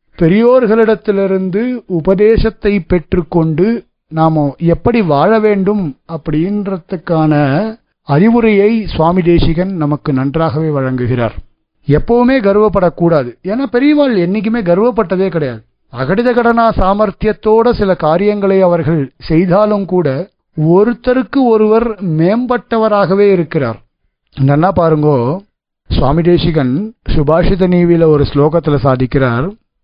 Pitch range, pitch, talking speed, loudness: 155-215 Hz, 180 Hz, 85 wpm, -12 LUFS